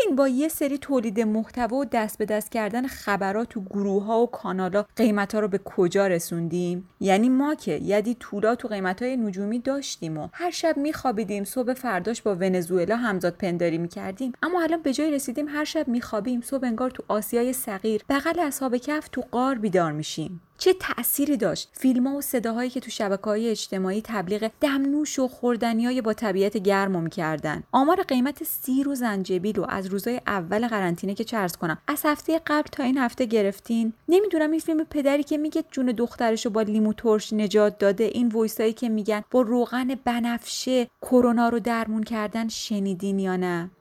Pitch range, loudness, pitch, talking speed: 200-260 Hz, -25 LUFS, 230 Hz, 180 wpm